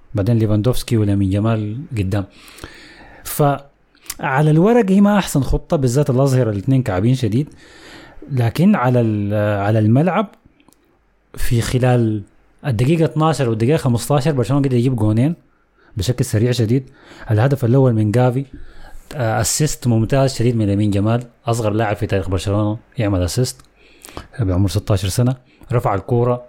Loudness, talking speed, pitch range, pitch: -17 LUFS, 125 wpm, 105-135 Hz, 120 Hz